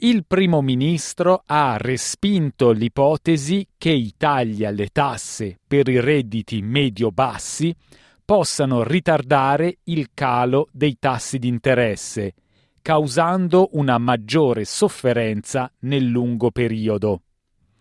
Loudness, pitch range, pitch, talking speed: -20 LUFS, 115-155 Hz, 135 Hz, 100 wpm